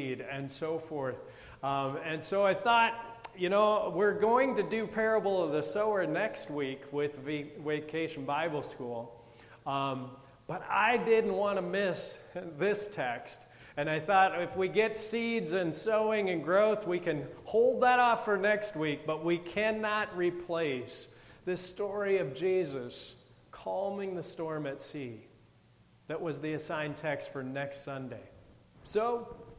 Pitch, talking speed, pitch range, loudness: 170 Hz, 150 wpm, 140-205 Hz, -32 LUFS